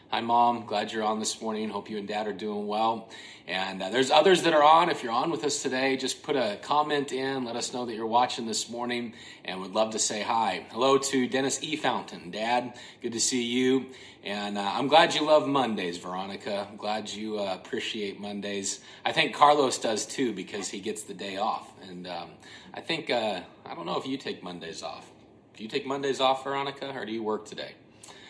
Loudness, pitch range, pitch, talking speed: -27 LUFS, 105-135 Hz, 120 Hz, 225 wpm